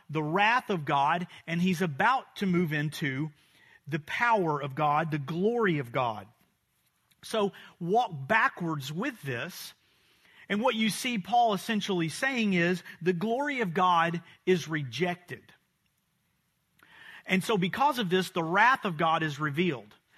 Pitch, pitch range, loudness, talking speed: 180 Hz, 160-215 Hz, -28 LUFS, 145 wpm